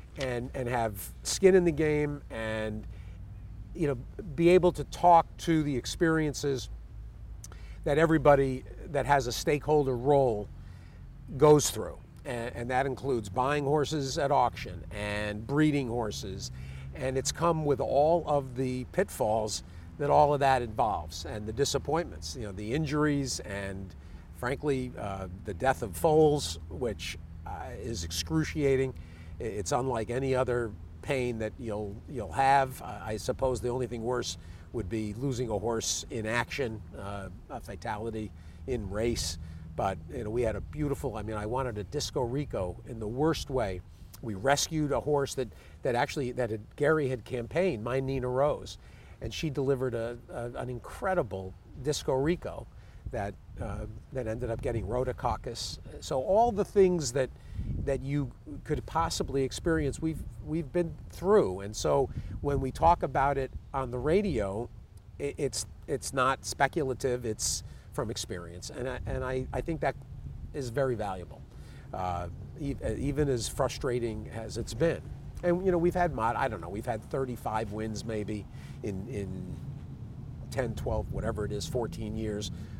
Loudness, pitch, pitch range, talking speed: -30 LUFS, 120 Hz, 105-140 Hz, 155 wpm